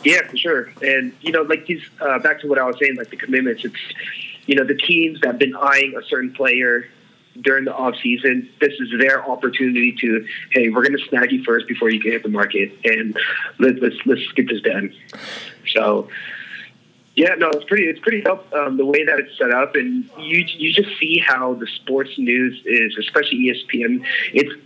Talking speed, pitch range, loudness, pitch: 210 wpm, 125-160 Hz, -18 LUFS, 135 Hz